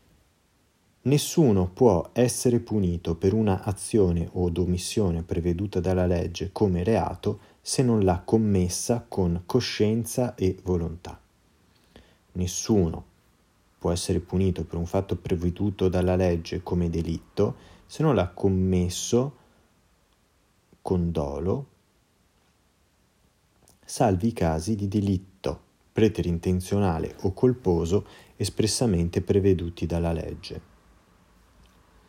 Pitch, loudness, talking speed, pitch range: 95 Hz, -26 LUFS, 95 wpm, 85-105 Hz